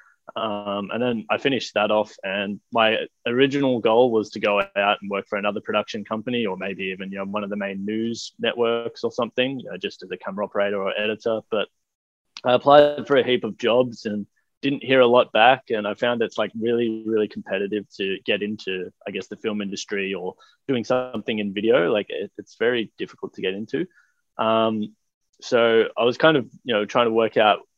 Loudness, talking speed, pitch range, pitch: -22 LUFS, 210 wpm, 100-120 Hz, 110 Hz